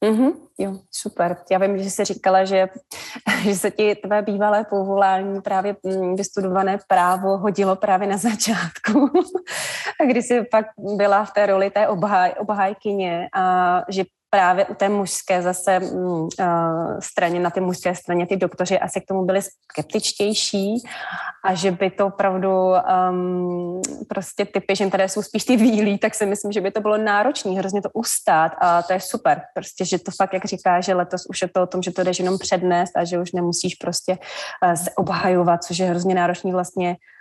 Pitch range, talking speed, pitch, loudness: 180-210 Hz, 180 wpm, 195 Hz, -20 LUFS